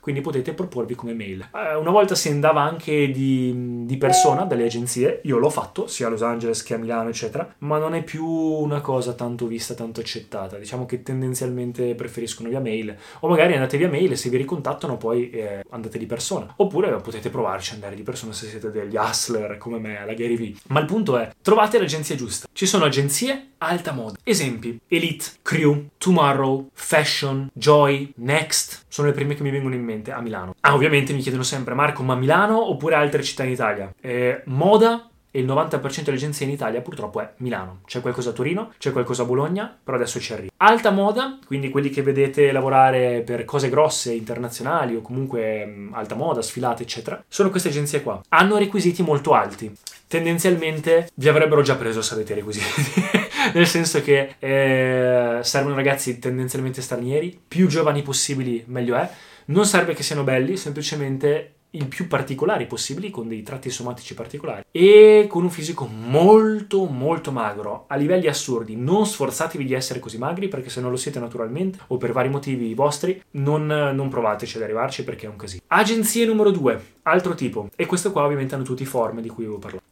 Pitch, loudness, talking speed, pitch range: 135 Hz, -21 LUFS, 190 wpm, 120-160 Hz